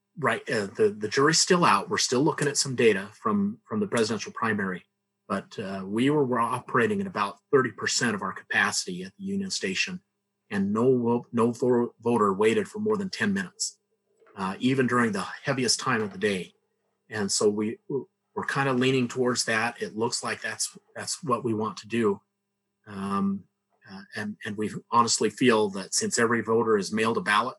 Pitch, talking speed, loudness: 125 Hz, 185 wpm, -26 LUFS